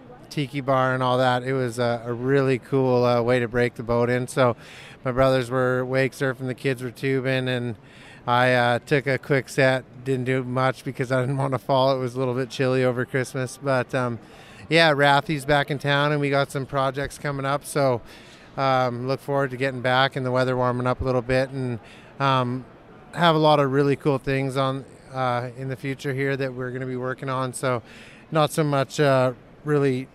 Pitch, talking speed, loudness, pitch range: 130 Hz, 215 wpm, -23 LUFS, 125-140 Hz